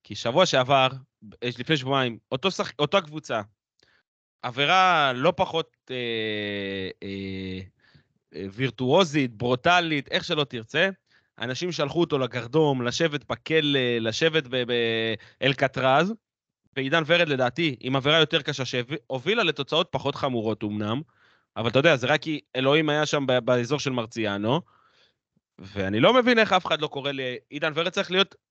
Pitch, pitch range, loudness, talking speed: 135 Hz, 120-160 Hz, -24 LUFS, 140 wpm